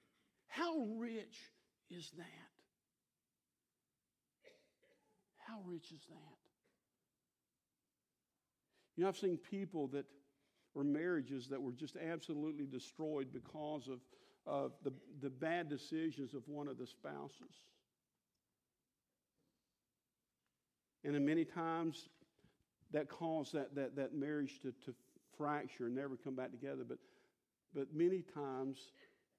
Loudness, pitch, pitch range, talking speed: -44 LUFS, 145 Hz, 135-165 Hz, 110 wpm